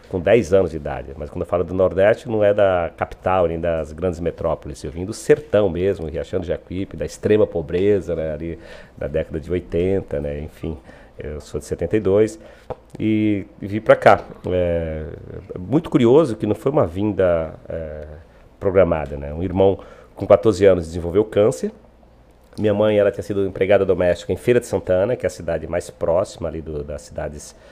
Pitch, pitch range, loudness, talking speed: 90 Hz, 80-100 Hz, -20 LUFS, 185 wpm